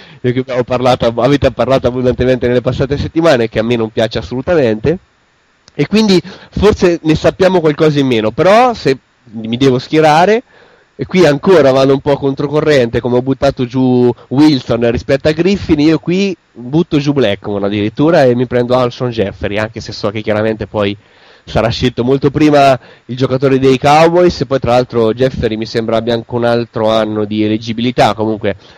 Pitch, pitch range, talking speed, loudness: 125 Hz, 115-150 Hz, 175 wpm, -12 LUFS